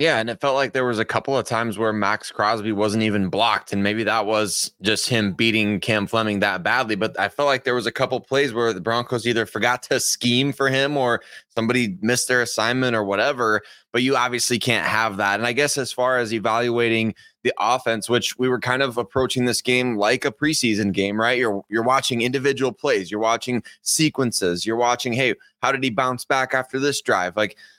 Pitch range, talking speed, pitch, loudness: 110-130 Hz, 220 wpm, 120 Hz, -21 LUFS